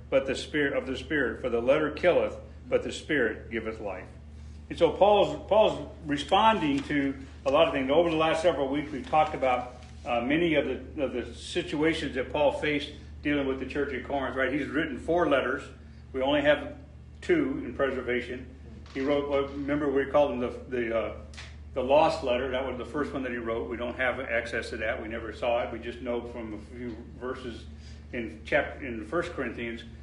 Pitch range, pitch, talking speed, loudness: 115-145 Hz, 125 Hz, 205 wpm, -28 LUFS